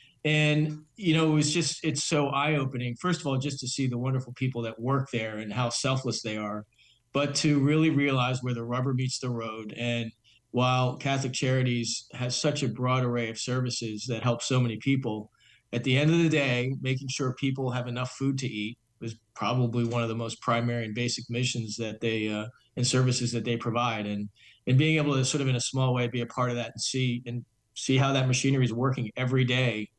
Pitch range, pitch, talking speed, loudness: 115-135 Hz, 125 Hz, 220 wpm, -28 LUFS